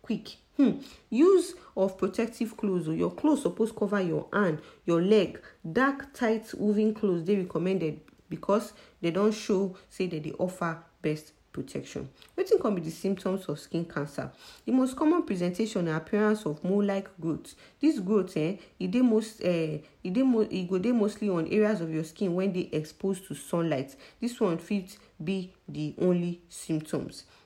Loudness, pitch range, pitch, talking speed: -29 LUFS, 170-215 Hz, 190 Hz, 155 wpm